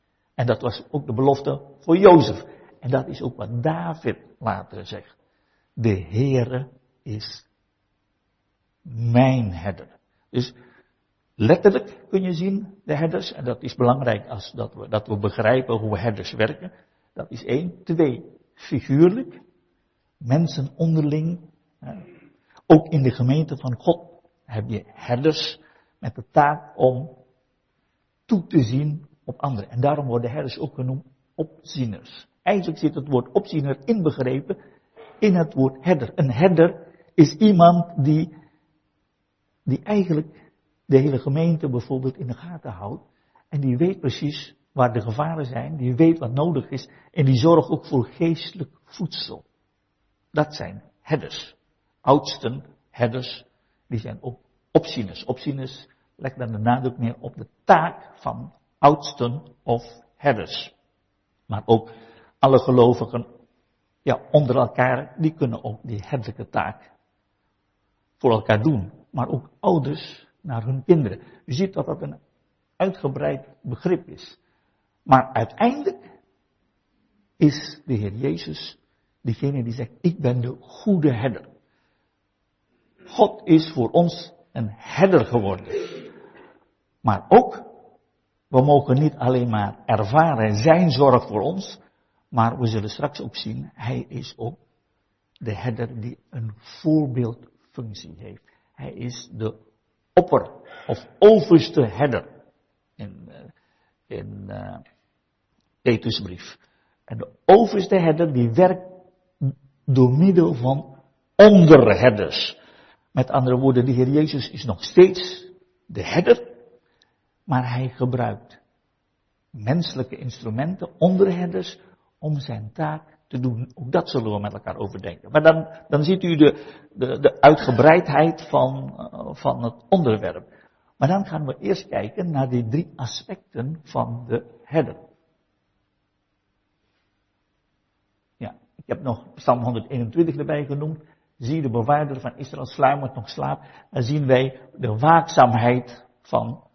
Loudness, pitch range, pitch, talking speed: -21 LUFS, 120-155 Hz, 130 Hz, 130 wpm